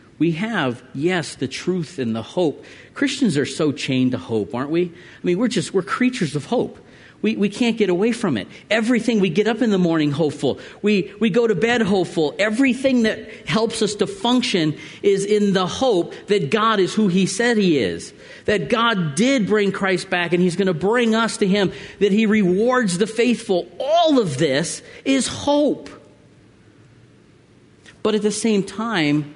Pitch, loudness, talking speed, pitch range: 200 Hz, -20 LUFS, 190 wpm, 170-225 Hz